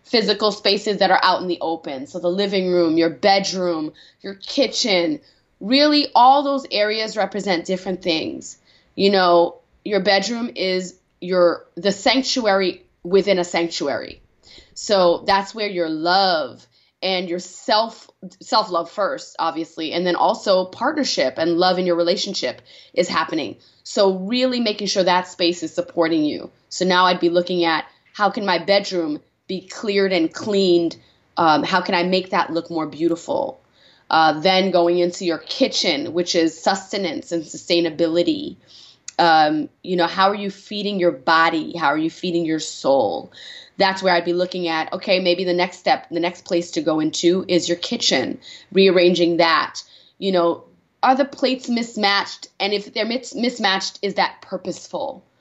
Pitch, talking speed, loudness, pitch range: 185 Hz, 160 wpm, -19 LUFS, 170-200 Hz